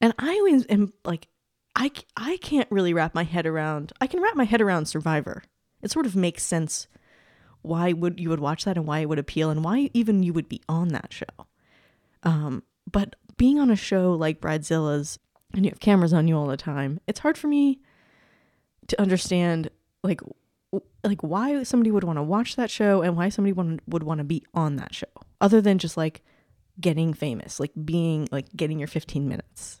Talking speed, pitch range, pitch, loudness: 205 wpm, 155-210 Hz, 175 Hz, -25 LUFS